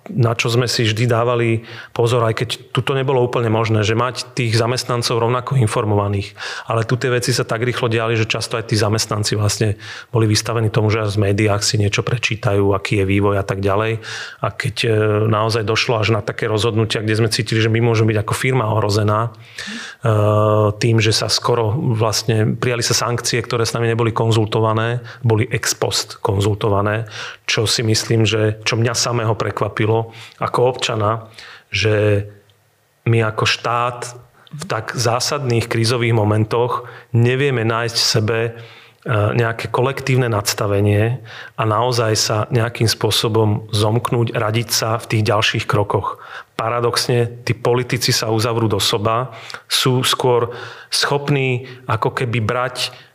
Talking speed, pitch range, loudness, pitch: 150 wpm, 110-125 Hz, -18 LUFS, 115 Hz